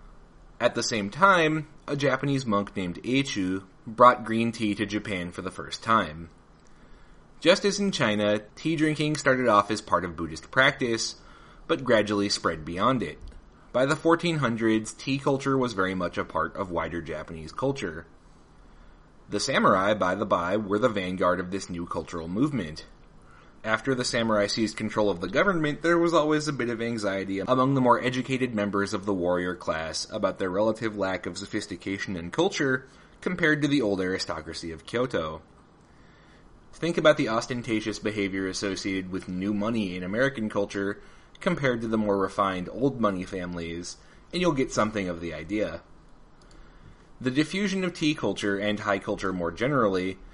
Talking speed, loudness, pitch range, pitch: 165 wpm, -26 LUFS, 90-130 Hz, 105 Hz